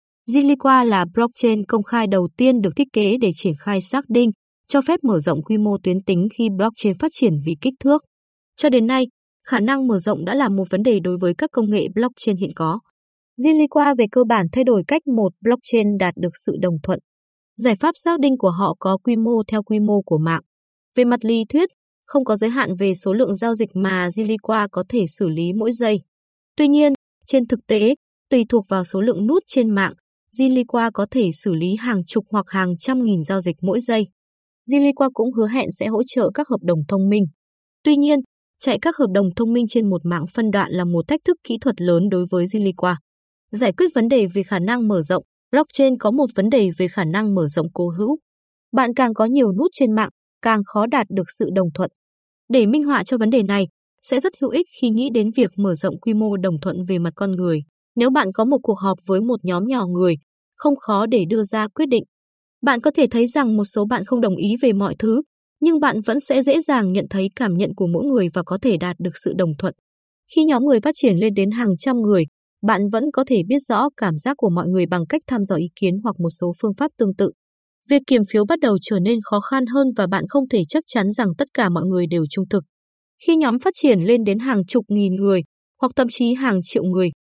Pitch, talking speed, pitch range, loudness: 220 Hz, 240 wpm, 190-255 Hz, -19 LUFS